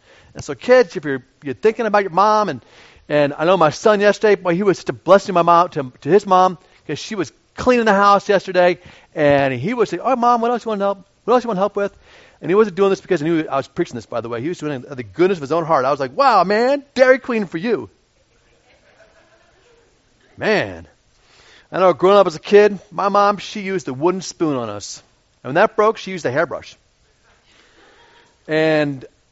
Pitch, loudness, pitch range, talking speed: 190 Hz, -17 LUFS, 155-215 Hz, 235 wpm